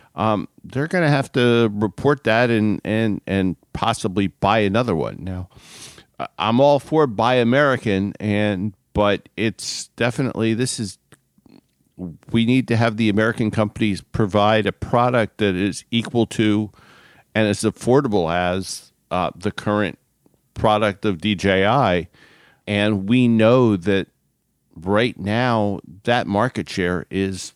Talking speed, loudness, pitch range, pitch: 135 wpm, -20 LUFS, 100-115 Hz, 110 Hz